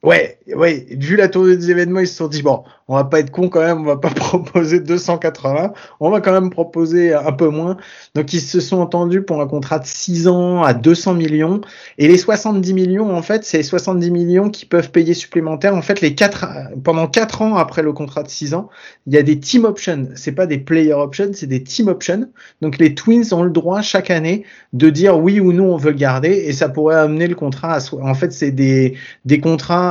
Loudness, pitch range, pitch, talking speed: -15 LUFS, 155-185 Hz, 170 Hz, 240 wpm